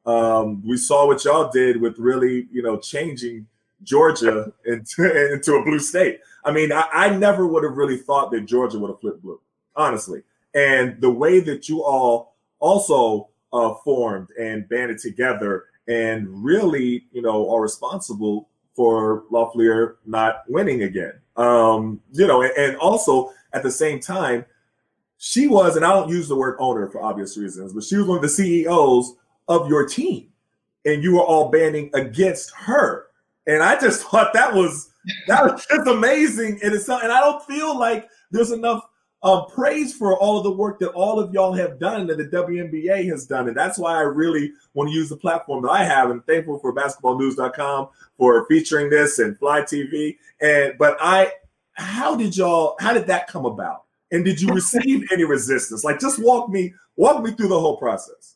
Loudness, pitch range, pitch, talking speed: -19 LUFS, 120-190 Hz, 150 Hz, 185 wpm